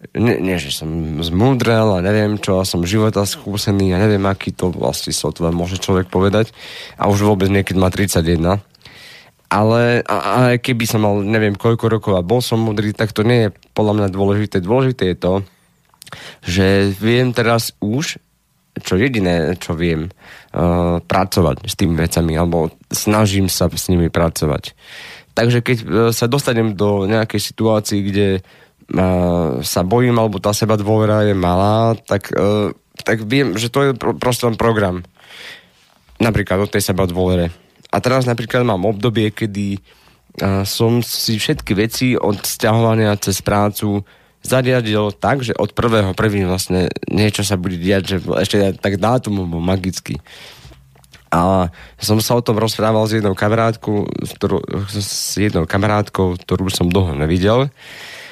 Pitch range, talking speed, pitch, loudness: 95-110 Hz, 150 wpm, 100 Hz, -16 LUFS